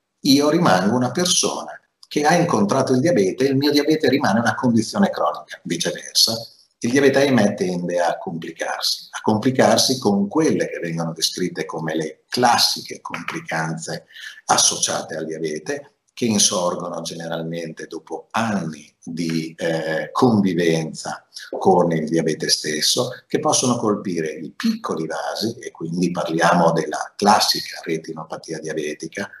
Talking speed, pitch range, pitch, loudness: 130 wpm, 80-125 Hz, 85 Hz, -20 LUFS